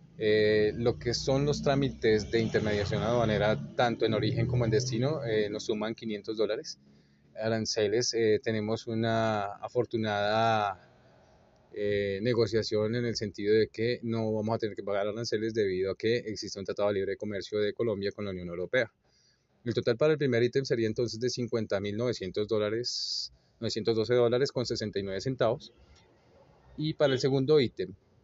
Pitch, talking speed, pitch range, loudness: 110 Hz, 155 wpm, 105-120 Hz, -30 LUFS